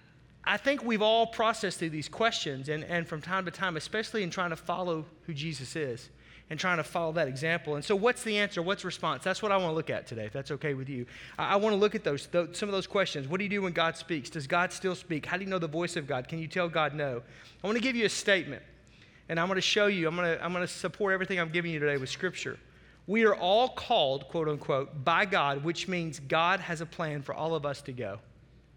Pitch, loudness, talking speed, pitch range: 170 Hz, -30 LUFS, 270 wpm, 150-190 Hz